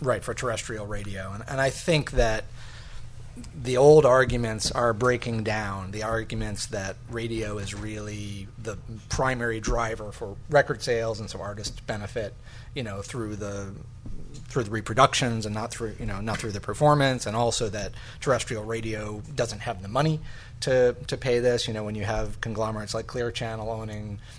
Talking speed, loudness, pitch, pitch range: 170 wpm, -27 LUFS, 115 Hz, 105-125 Hz